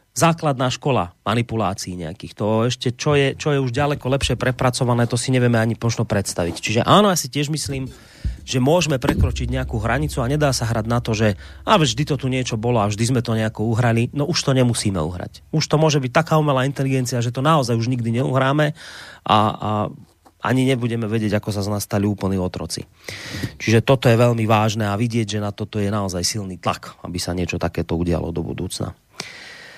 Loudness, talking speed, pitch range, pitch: -20 LUFS, 205 wpm, 105-135 Hz, 120 Hz